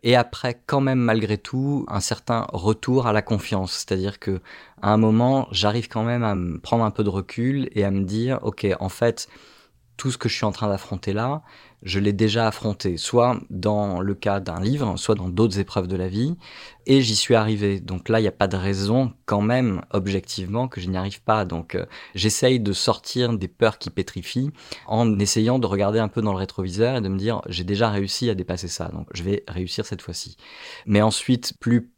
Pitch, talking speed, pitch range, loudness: 105 Hz, 220 wpm, 95-120 Hz, -23 LUFS